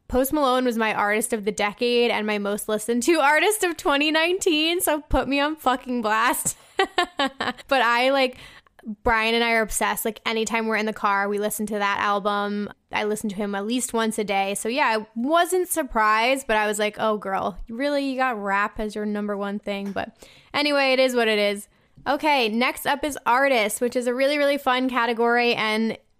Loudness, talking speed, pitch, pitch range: -22 LUFS, 205 wpm, 235 Hz, 215-275 Hz